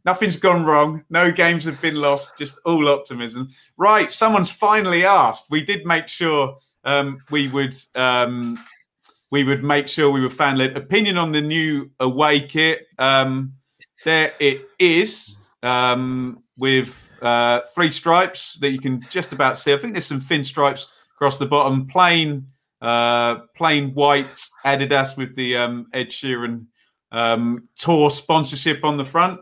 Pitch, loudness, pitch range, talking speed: 140 Hz, -18 LUFS, 130-160 Hz, 155 wpm